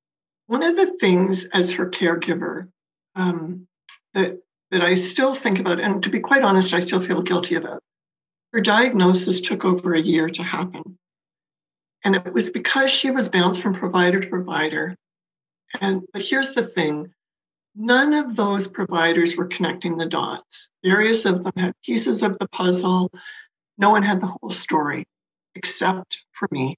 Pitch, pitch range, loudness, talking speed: 185 Hz, 175-205 Hz, -20 LUFS, 165 wpm